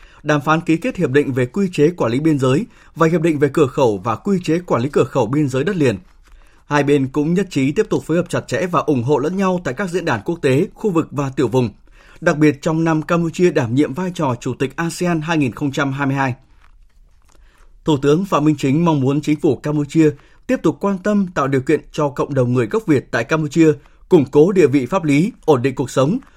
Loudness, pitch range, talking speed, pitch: -17 LUFS, 135-170 Hz, 240 wpm, 150 Hz